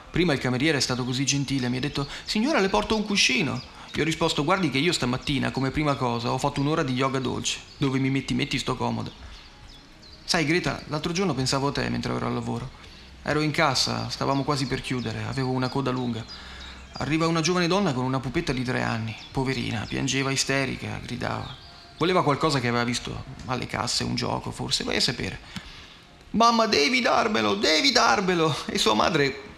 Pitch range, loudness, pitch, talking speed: 125-155 Hz, -25 LUFS, 135 Hz, 190 wpm